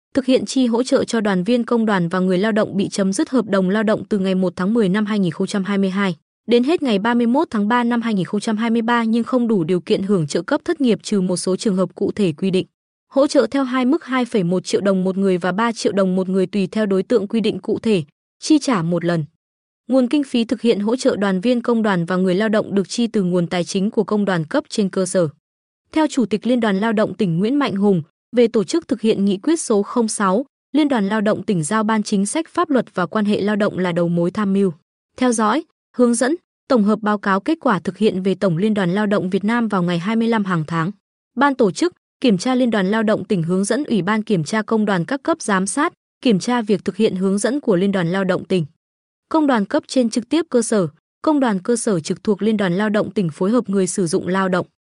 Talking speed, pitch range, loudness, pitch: 260 wpm, 190-240 Hz, -19 LUFS, 215 Hz